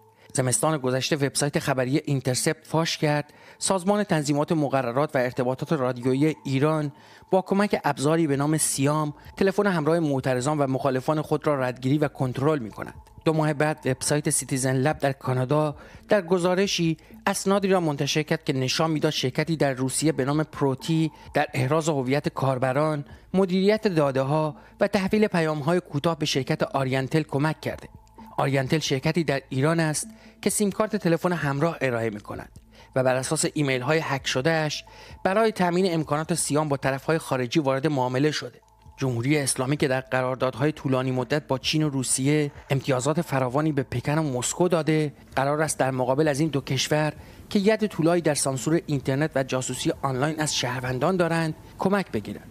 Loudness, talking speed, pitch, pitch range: -24 LUFS, 160 wpm, 150 Hz, 135-160 Hz